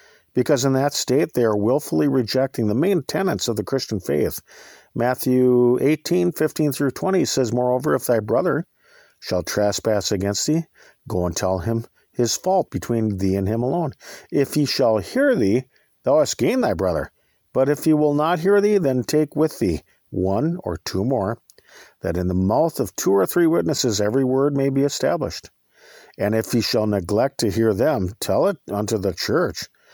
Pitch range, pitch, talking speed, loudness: 105-145 Hz, 125 Hz, 180 wpm, -21 LUFS